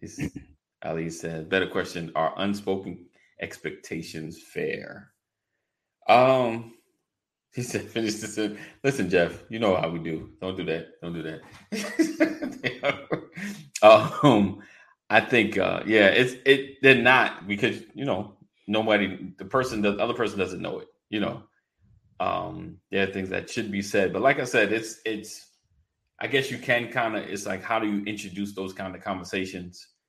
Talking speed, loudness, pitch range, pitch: 160 wpm, -25 LUFS, 95-125 Hz, 105 Hz